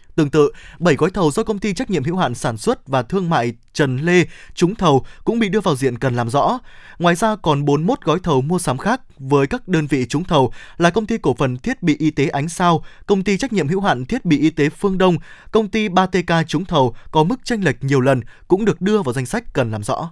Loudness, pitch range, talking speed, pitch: -18 LUFS, 140-195 Hz, 260 wpm, 160 Hz